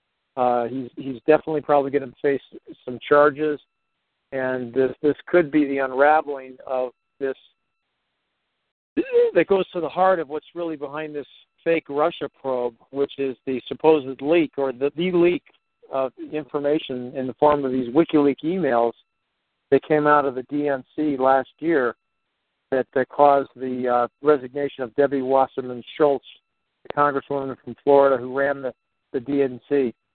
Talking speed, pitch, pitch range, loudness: 155 wpm, 140 Hz, 130-150 Hz, -22 LUFS